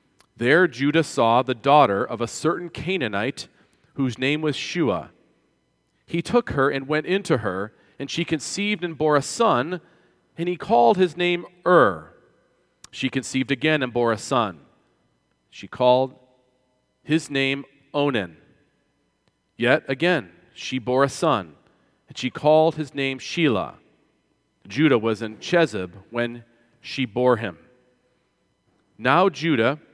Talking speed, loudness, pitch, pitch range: 135 wpm, -22 LUFS, 140 Hz, 125-160 Hz